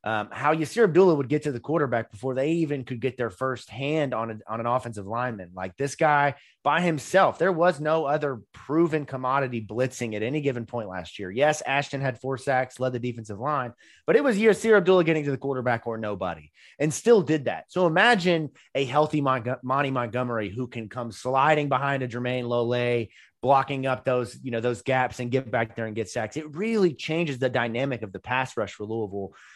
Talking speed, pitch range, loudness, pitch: 215 wpm, 120-150 Hz, -25 LUFS, 130 Hz